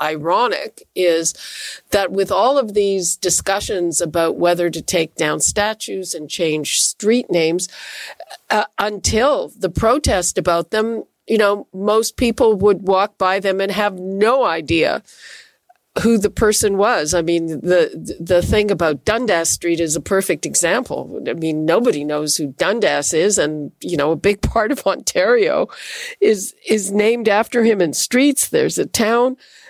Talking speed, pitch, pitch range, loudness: 155 wpm, 195 Hz, 170-220 Hz, -17 LUFS